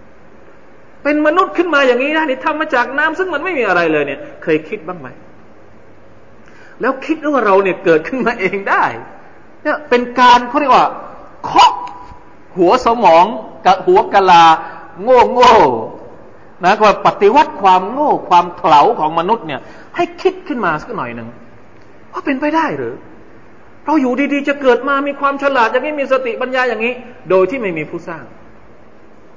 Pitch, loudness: 245 Hz, -13 LUFS